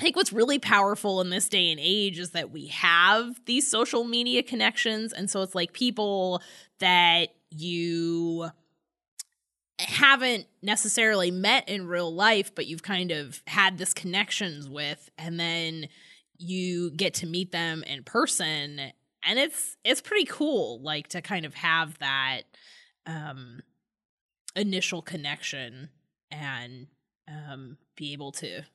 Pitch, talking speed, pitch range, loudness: 175 Hz, 140 wpm, 155-210 Hz, -25 LUFS